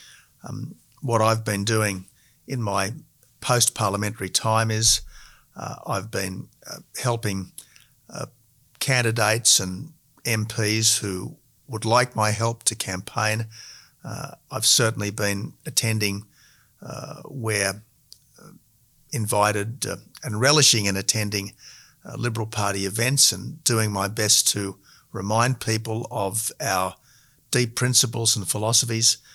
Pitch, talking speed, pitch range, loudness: 110 Hz, 120 wpm, 105-125 Hz, -22 LUFS